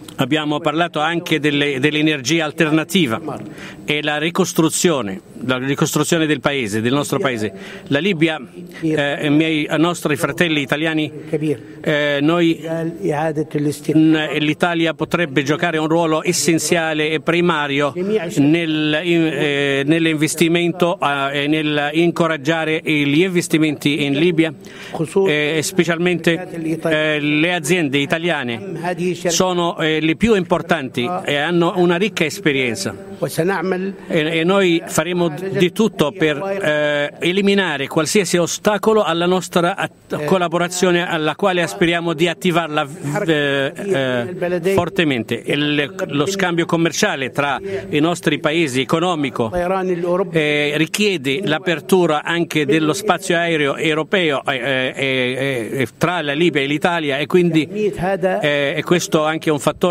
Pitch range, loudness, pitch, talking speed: 150-175 Hz, -17 LUFS, 160 Hz, 120 wpm